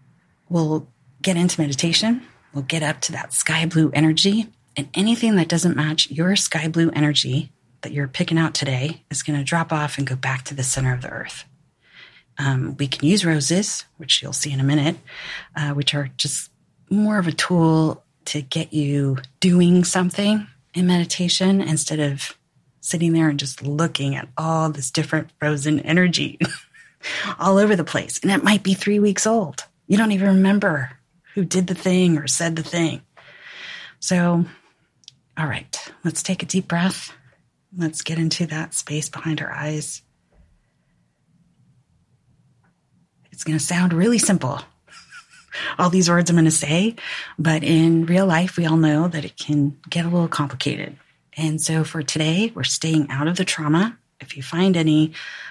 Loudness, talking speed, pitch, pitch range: -20 LUFS, 170 wpm, 160 Hz, 145-180 Hz